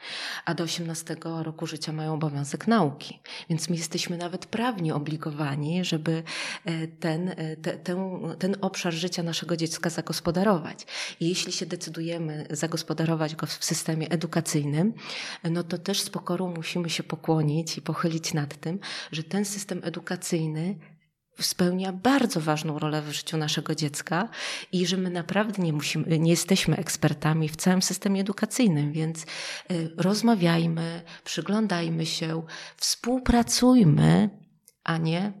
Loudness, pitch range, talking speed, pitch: -27 LUFS, 160-185 Hz, 130 wpm, 170 Hz